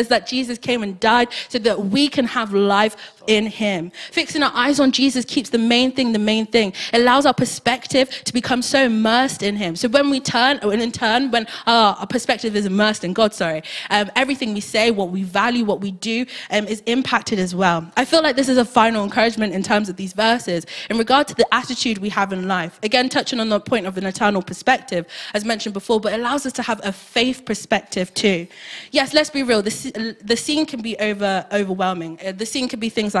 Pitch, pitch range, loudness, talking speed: 225 Hz, 200-250 Hz, -19 LUFS, 230 wpm